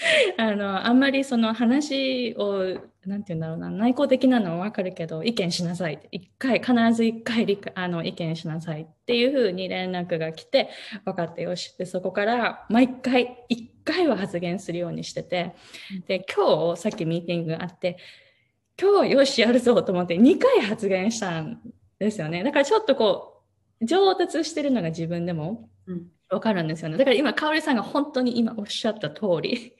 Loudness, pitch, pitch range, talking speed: -24 LUFS, 210 Hz, 175-250 Hz, 350 characters per minute